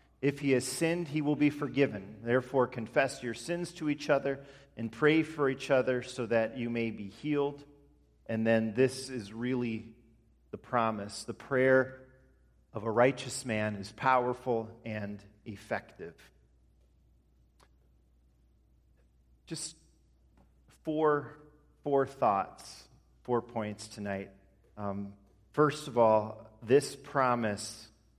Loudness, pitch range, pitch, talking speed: -32 LUFS, 100-135 Hz, 115 Hz, 120 wpm